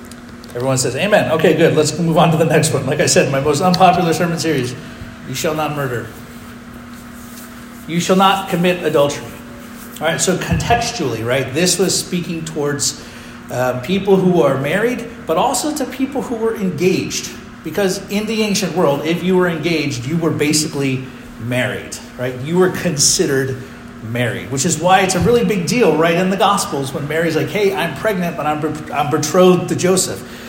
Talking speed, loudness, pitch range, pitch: 180 wpm, -16 LUFS, 135-185 Hz, 165 Hz